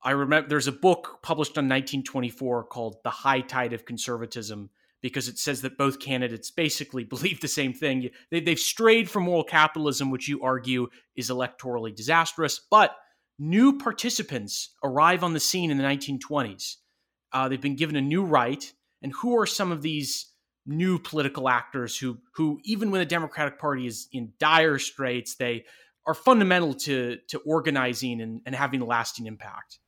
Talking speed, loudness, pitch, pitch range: 175 wpm, -26 LUFS, 140 Hz, 125-160 Hz